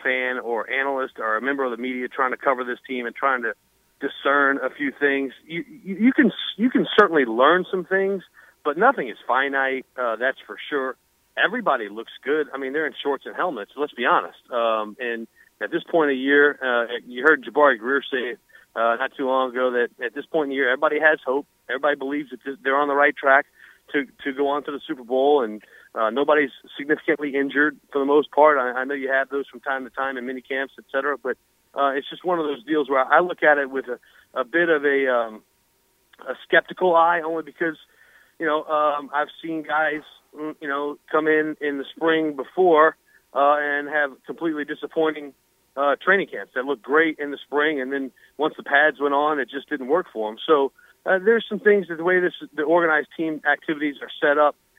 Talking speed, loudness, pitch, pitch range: 225 wpm, -22 LUFS, 145 Hz, 135-155 Hz